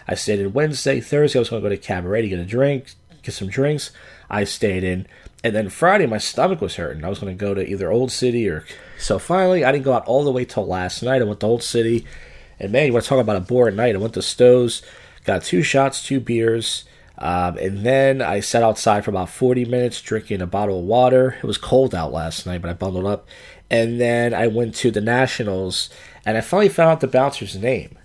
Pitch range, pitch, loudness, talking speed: 100-130 Hz, 115 Hz, -19 LUFS, 245 wpm